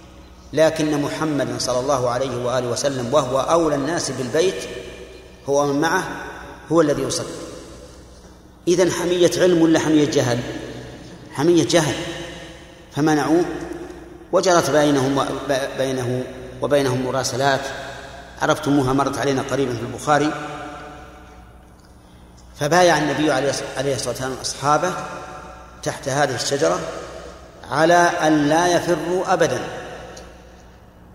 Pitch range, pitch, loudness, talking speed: 130-165 Hz, 145 Hz, -20 LUFS, 100 wpm